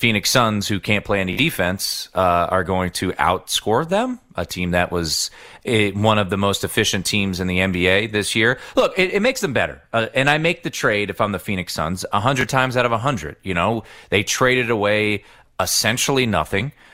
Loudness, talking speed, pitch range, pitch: -19 LUFS, 200 wpm, 95-125 Hz, 105 Hz